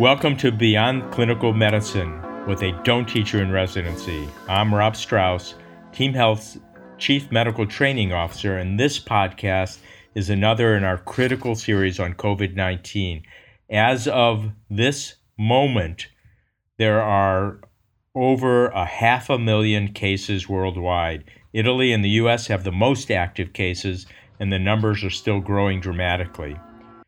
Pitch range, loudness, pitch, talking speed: 95-115 Hz, -21 LUFS, 105 Hz, 135 wpm